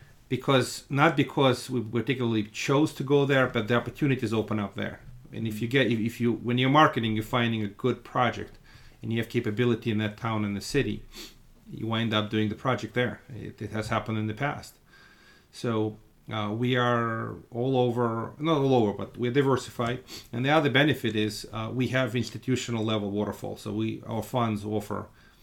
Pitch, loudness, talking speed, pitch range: 115 Hz, -27 LUFS, 190 wpm, 110-125 Hz